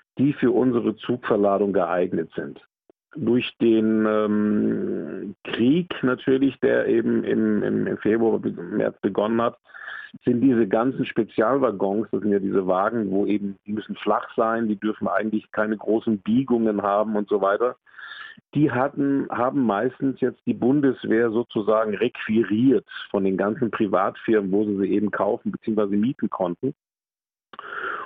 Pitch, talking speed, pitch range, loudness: 110 Hz, 135 wpm, 105-125 Hz, -23 LUFS